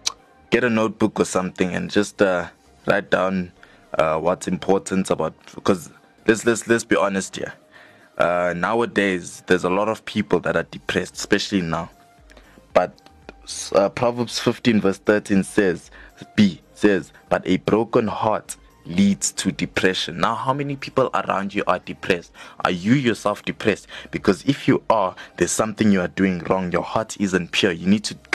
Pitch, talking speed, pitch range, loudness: 105 Hz, 165 wpm, 95-115 Hz, -21 LUFS